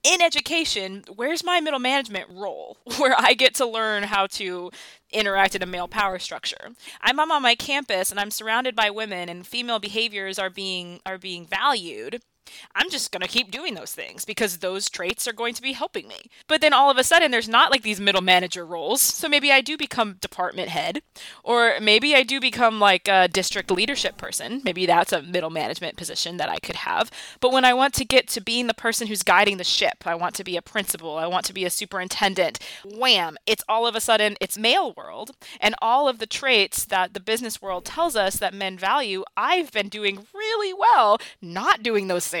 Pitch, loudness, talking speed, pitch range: 215 Hz, -21 LUFS, 215 wpm, 190-255 Hz